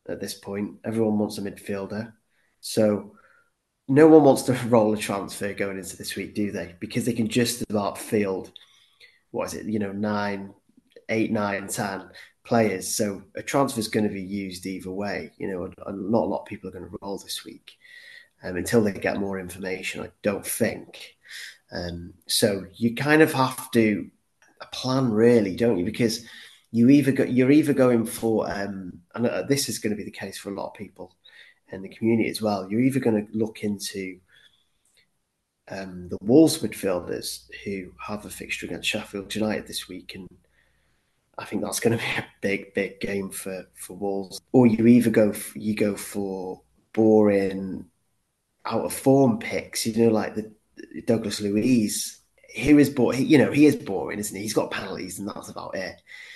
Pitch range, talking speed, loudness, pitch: 100-120 Hz, 190 wpm, -24 LUFS, 105 Hz